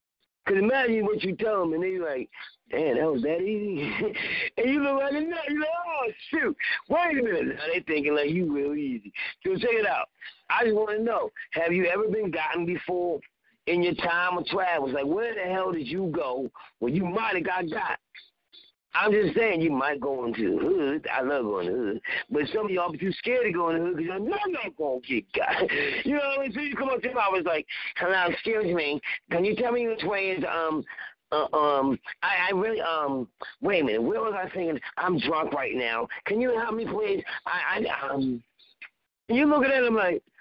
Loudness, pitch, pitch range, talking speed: -27 LUFS, 205 Hz, 170-275 Hz, 230 wpm